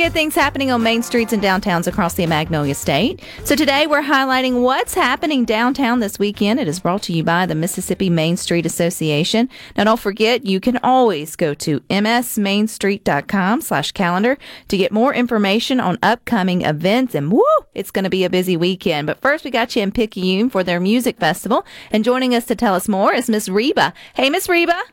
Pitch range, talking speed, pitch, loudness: 180-245 Hz, 195 wpm, 215 Hz, -17 LUFS